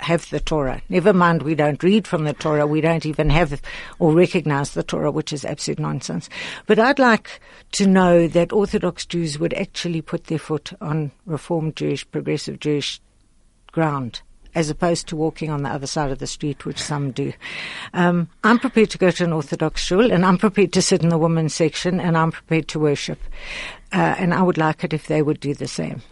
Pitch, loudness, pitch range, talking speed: 160 Hz, -20 LUFS, 150-180 Hz, 210 wpm